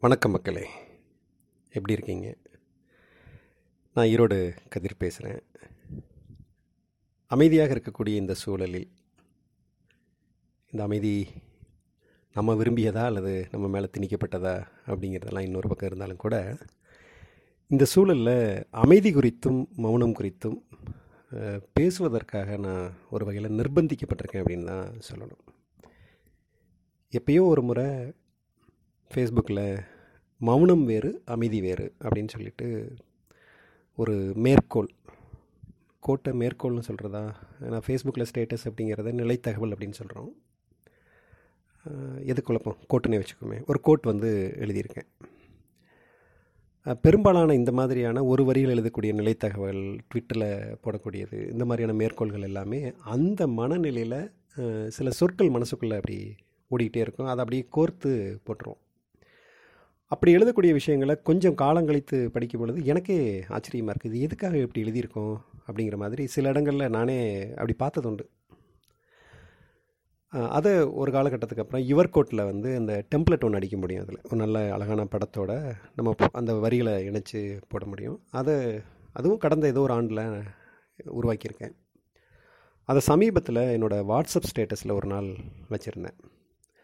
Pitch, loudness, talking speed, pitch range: 115 Hz, -26 LUFS, 105 wpm, 105-130 Hz